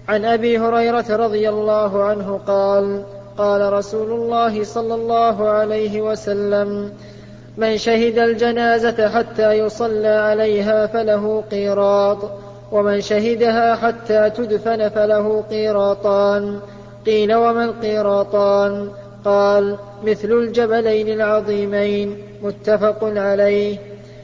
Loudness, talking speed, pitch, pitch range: -17 LUFS, 90 wpm, 215 Hz, 205-225 Hz